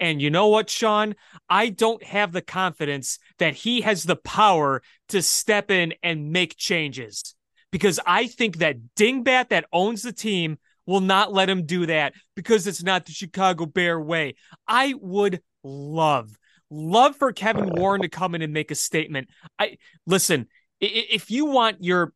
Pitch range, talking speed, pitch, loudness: 160-210 Hz, 170 wpm, 185 Hz, -22 LUFS